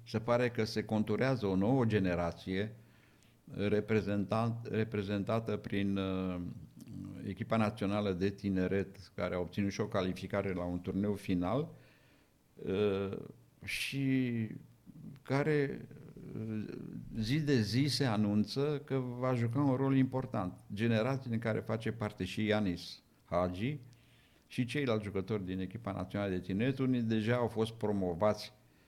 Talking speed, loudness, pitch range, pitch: 125 wpm, -35 LUFS, 100-120 Hz, 110 Hz